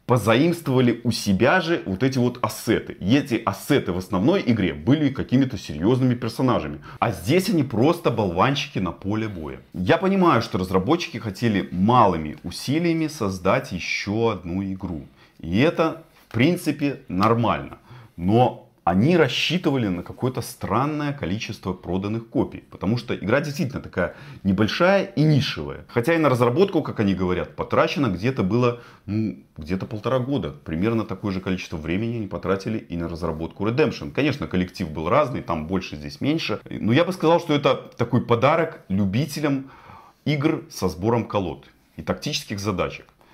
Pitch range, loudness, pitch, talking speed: 95-140 Hz, -23 LUFS, 115 Hz, 150 wpm